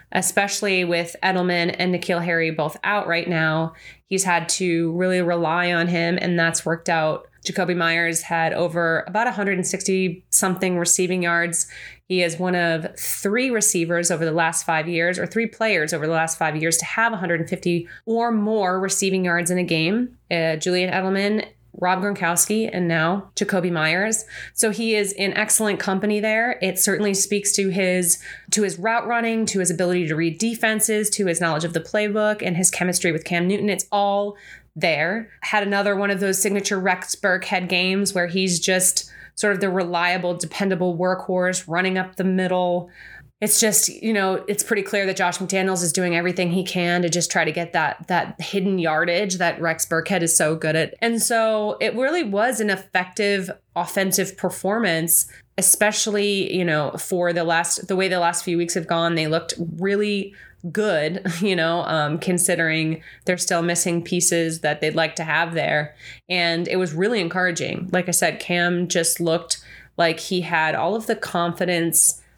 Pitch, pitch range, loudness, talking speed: 180 Hz, 170-200 Hz, -21 LUFS, 180 wpm